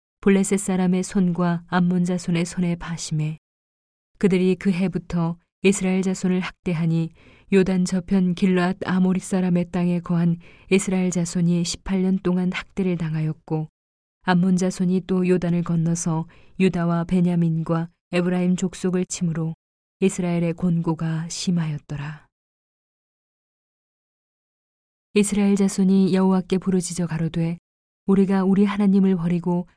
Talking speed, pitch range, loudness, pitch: 285 characters per minute, 170-190 Hz, -22 LUFS, 180 Hz